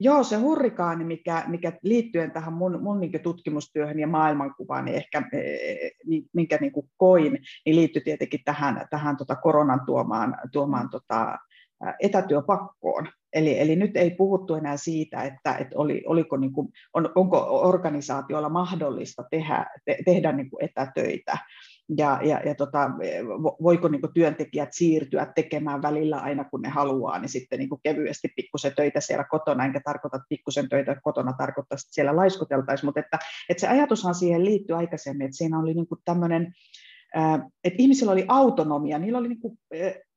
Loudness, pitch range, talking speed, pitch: -25 LUFS, 145-180 Hz, 150 wpm, 160 Hz